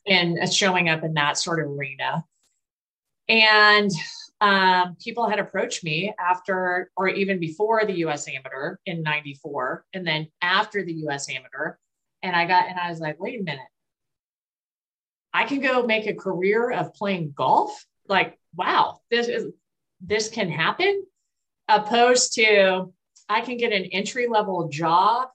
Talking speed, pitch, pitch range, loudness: 150 wpm, 190 Hz, 170-215 Hz, -22 LUFS